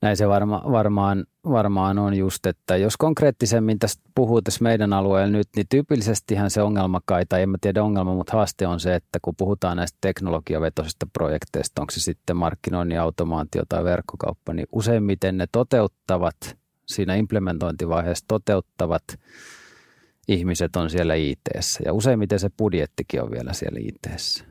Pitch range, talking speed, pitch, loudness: 90-105 Hz, 150 wpm, 95 Hz, -23 LUFS